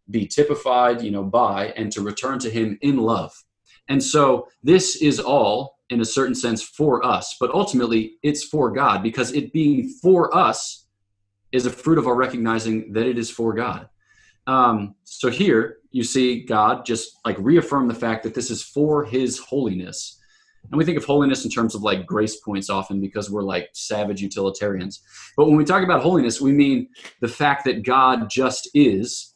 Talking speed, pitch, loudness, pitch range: 190 wpm, 125 Hz, -20 LUFS, 110-145 Hz